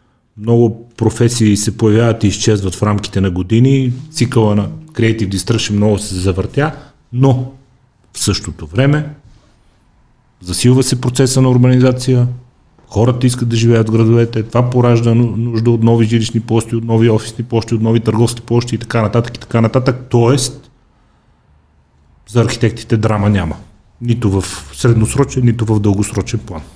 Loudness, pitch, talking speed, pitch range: -14 LUFS, 115 Hz, 145 wpm, 105-125 Hz